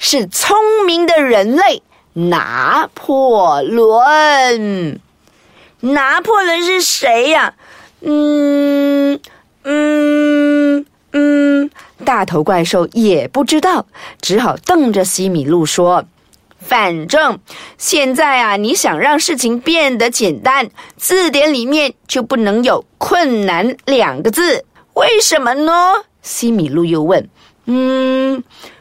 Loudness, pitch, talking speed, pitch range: -12 LUFS, 275 Hz, 150 characters per minute, 230-305 Hz